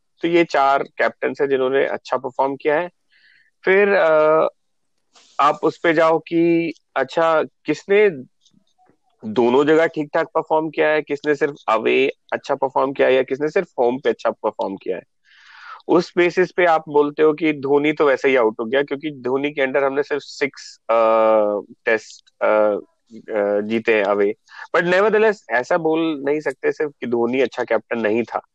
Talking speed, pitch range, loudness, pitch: 170 wpm, 135-170 Hz, -19 LUFS, 155 Hz